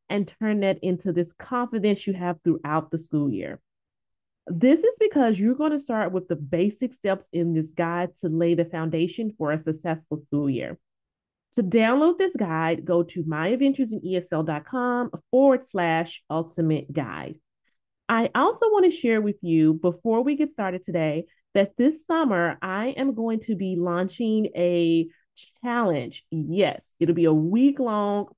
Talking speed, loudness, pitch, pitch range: 160 wpm, -24 LUFS, 185 Hz, 165-235 Hz